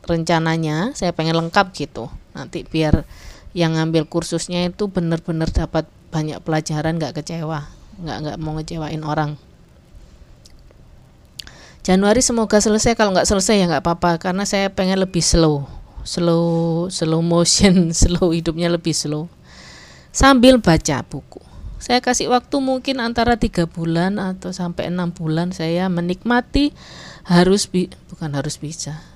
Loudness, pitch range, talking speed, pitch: -18 LUFS, 160-190 Hz, 130 wpm, 170 Hz